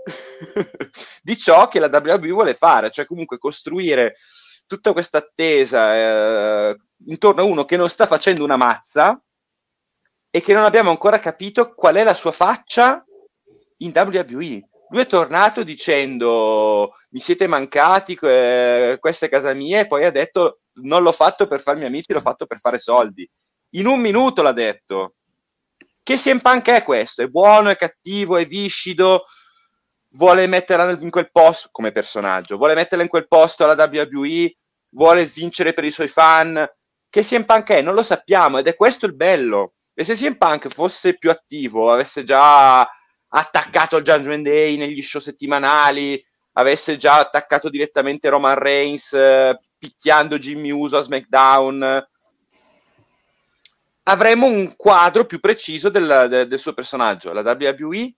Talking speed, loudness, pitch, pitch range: 155 wpm, -15 LUFS, 165 Hz, 140-210 Hz